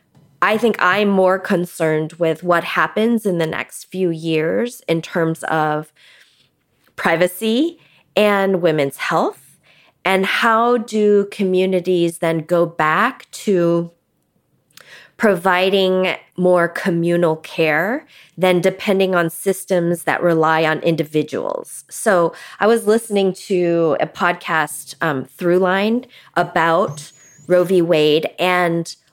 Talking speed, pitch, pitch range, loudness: 110 wpm, 180 Hz, 165-195 Hz, -17 LUFS